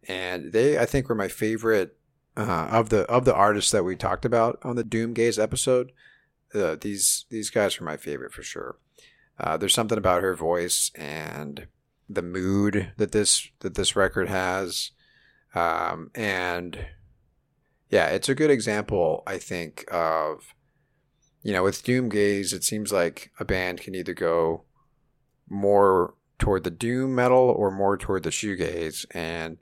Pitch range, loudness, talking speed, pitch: 90-120 Hz, -25 LUFS, 160 wpm, 100 Hz